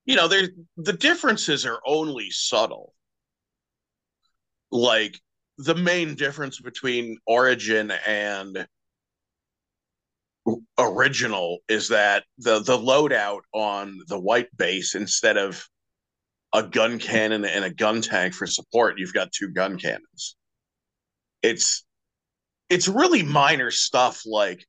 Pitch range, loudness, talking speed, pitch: 105-160 Hz, -22 LUFS, 115 wpm, 115 Hz